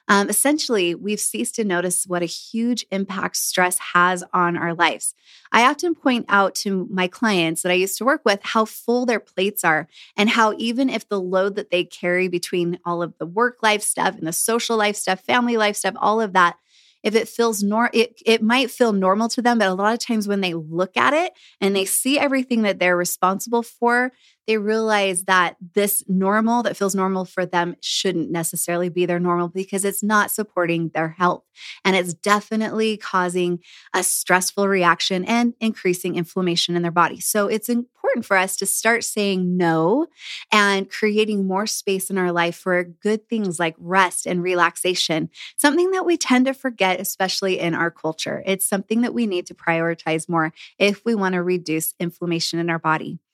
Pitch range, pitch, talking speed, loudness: 175-220 Hz, 195 Hz, 195 wpm, -20 LUFS